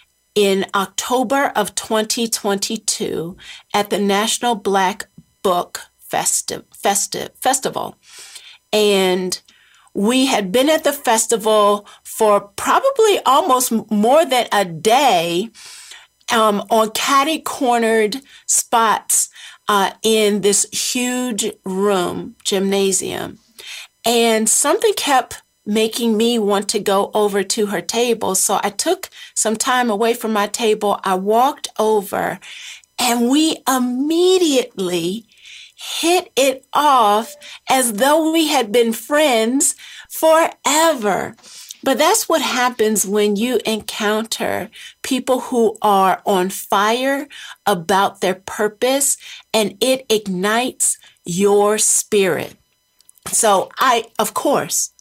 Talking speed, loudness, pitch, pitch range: 105 wpm, -17 LUFS, 225 Hz, 205-260 Hz